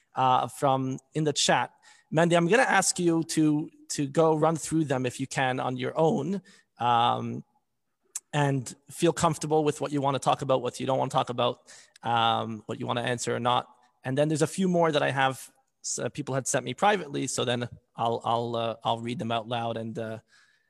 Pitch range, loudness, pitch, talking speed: 120-160 Hz, -27 LUFS, 135 Hz, 220 wpm